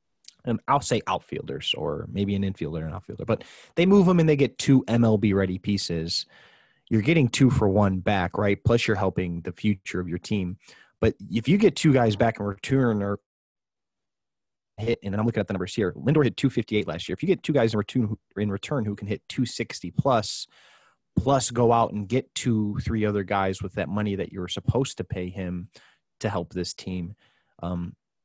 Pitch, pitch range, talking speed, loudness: 105 Hz, 95-120 Hz, 205 wpm, -25 LUFS